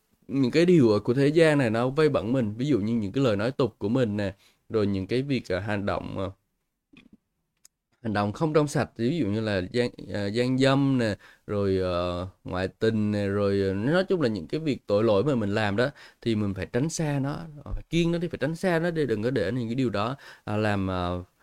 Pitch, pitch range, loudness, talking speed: 115 Hz, 100-135 Hz, -26 LUFS, 245 wpm